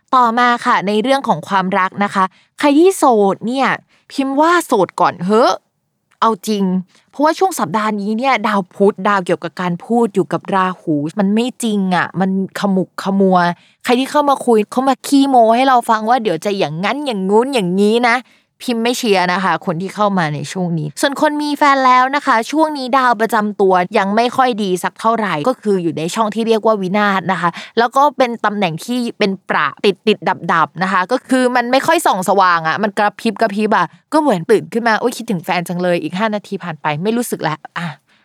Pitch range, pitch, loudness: 190-245 Hz, 215 Hz, -15 LUFS